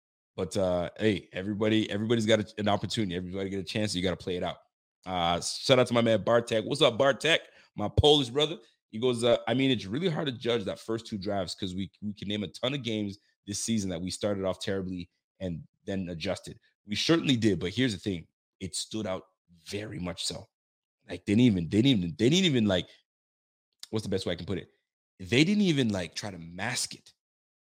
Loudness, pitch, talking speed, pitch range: -29 LUFS, 105 Hz, 230 wpm, 95-120 Hz